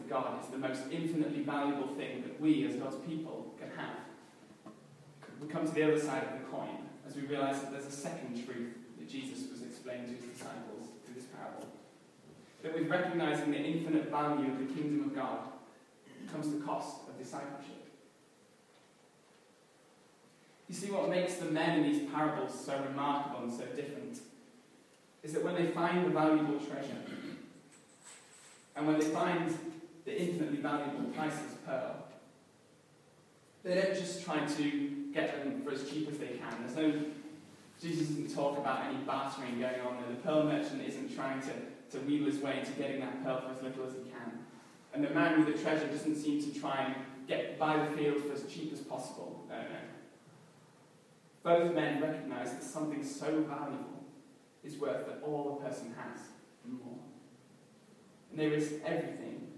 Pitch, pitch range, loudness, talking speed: 150 Hz, 135-160 Hz, -36 LUFS, 175 wpm